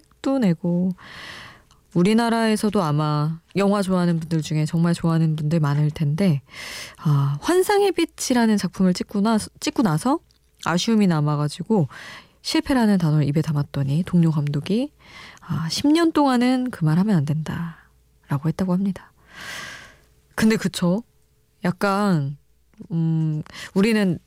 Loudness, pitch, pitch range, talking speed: -21 LUFS, 175 Hz, 155-215 Hz, 265 characters per minute